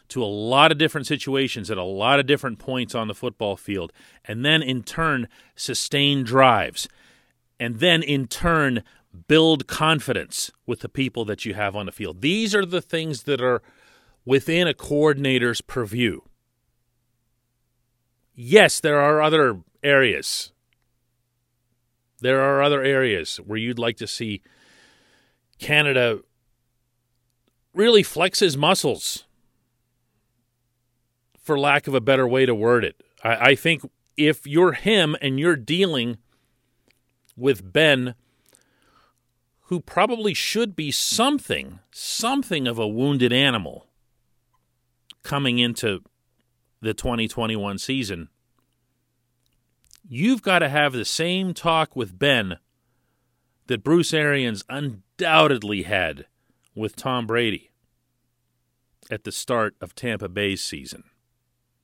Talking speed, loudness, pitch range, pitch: 120 wpm, -21 LUFS, 120-145 Hz, 125 Hz